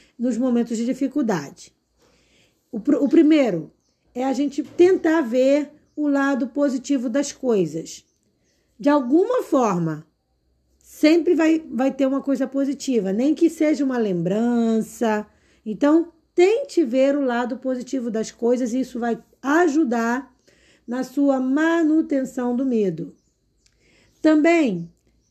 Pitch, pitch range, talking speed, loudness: 265 Hz, 235-295 Hz, 120 wpm, -21 LUFS